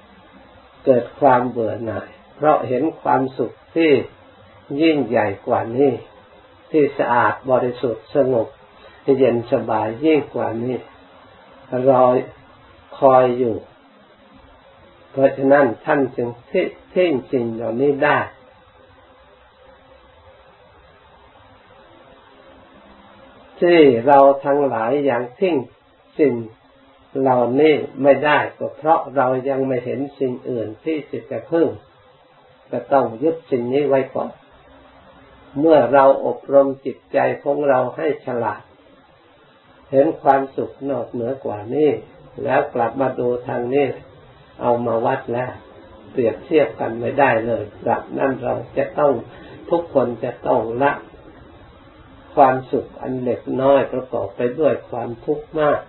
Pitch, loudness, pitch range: 130 Hz, -19 LUFS, 120-140 Hz